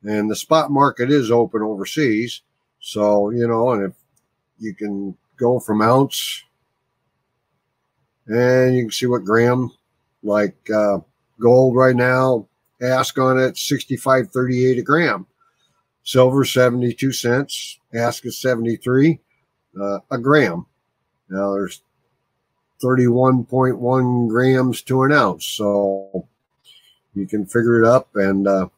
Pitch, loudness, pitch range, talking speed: 120 Hz, -18 LUFS, 105-130 Hz, 120 wpm